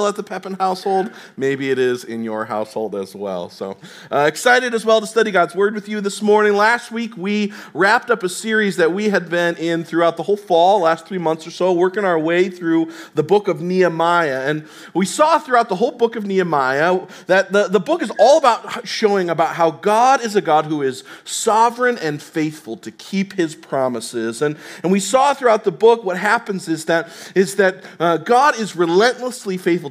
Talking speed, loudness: 210 wpm, -17 LUFS